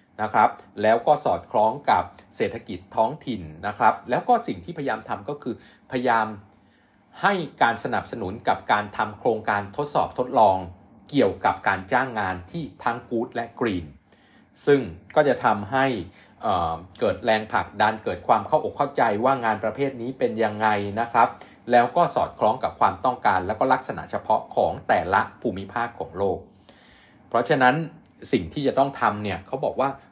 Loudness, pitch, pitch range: -24 LUFS, 115 Hz, 100-125 Hz